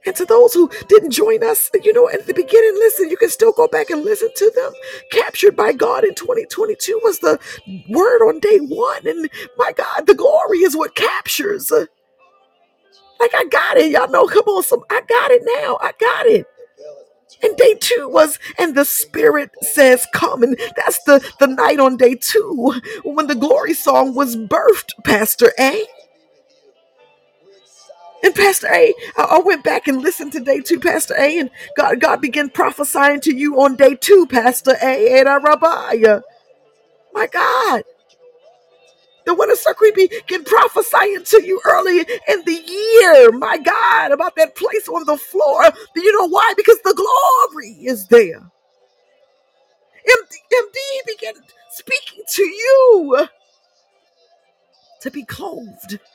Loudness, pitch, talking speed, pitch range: -14 LUFS, 390 Hz, 160 wpm, 300-455 Hz